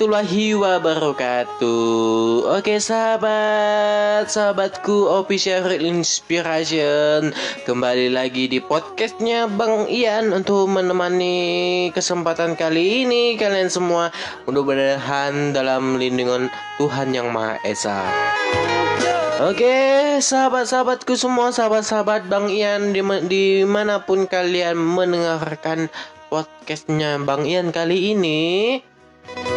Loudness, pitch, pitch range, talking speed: -19 LUFS, 180 Hz, 155-210 Hz, 85 wpm